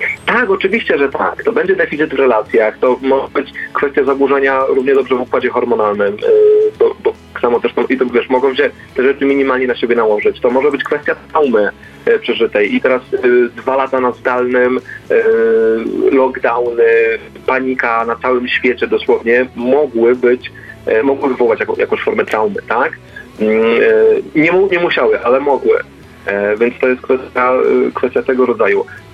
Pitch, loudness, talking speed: 140 Hz, -13 LUFS, 165 wpm